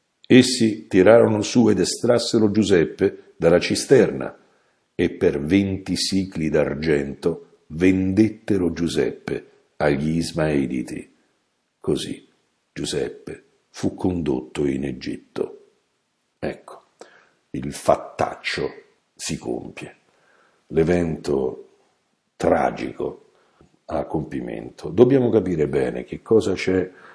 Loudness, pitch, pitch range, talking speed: -21 LUFS, 100 Hz, 80-125 Hz, 85 wpm